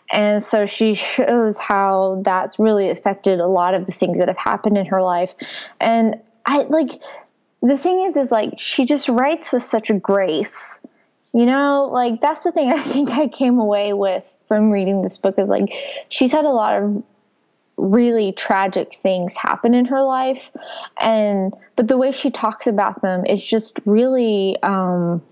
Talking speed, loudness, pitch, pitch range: 180 wpm, -18 LUFS, 220 Hz, 195-265 Hz